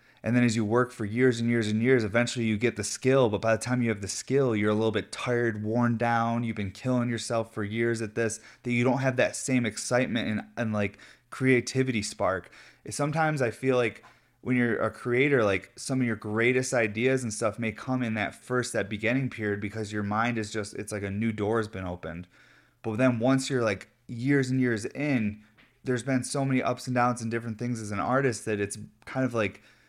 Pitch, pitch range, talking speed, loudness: 115 Hz, 110-125 Hz, 230 wpm, -28 LUFS